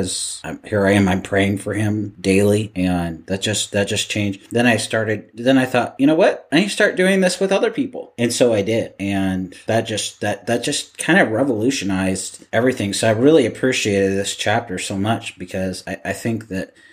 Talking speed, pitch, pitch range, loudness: 210 wpm, 105 Hz, 95-120 Hz, -19 LUFS